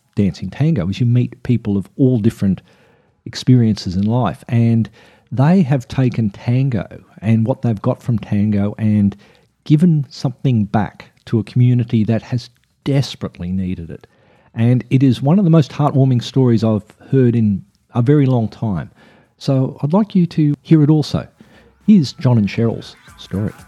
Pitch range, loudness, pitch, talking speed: 110-140 Hz, -16 LUFS, 120 Hz, 160 wpm